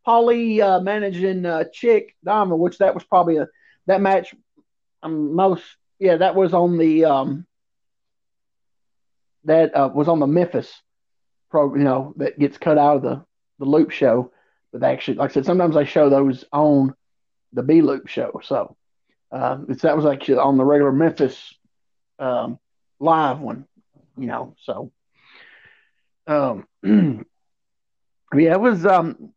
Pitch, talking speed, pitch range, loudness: 160 Hz, 155 wpm, 140-190 Hz, -19 LUFS